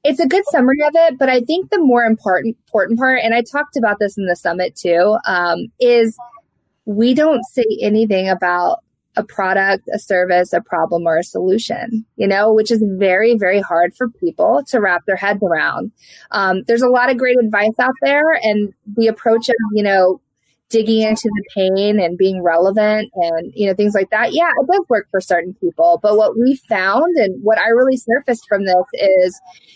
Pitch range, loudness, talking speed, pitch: 190-245 Hz, -15 LUFS, 200 wpm, 215 Hz